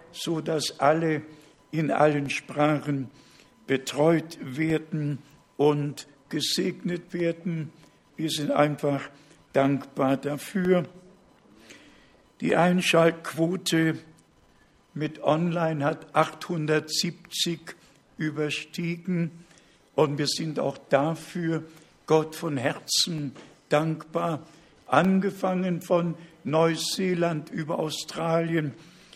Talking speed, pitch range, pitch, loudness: 75 wpm, 150-170 Hz, 160 Hz, -26 LUFS